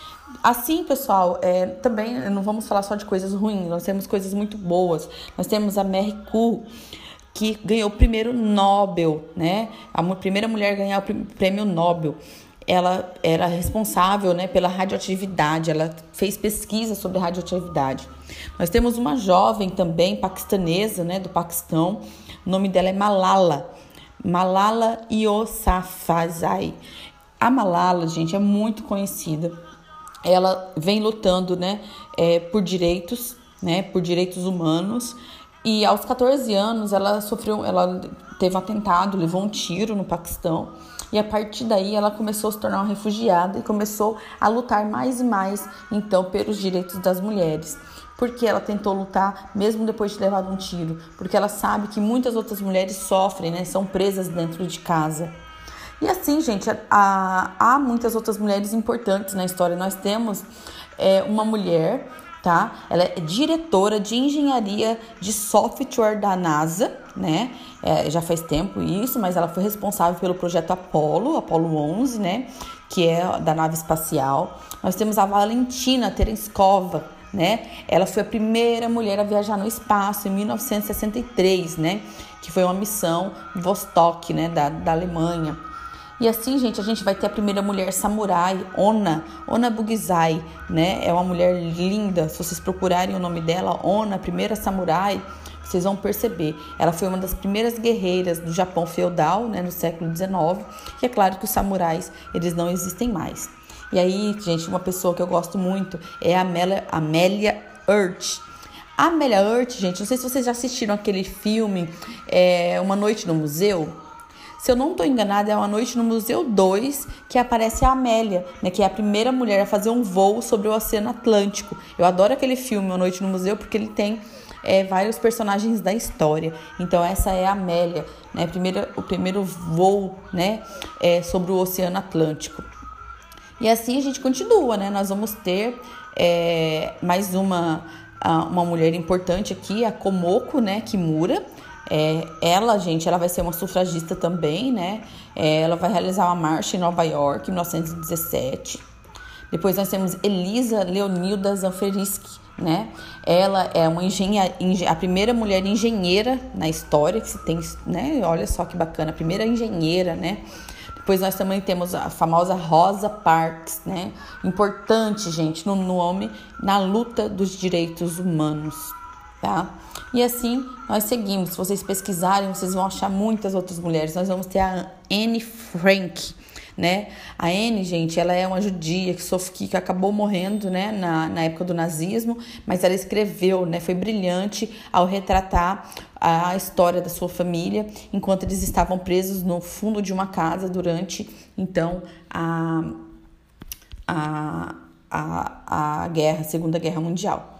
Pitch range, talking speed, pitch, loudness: 175-215 Hz, 160 wpm, 190 Hz, -22 LUFS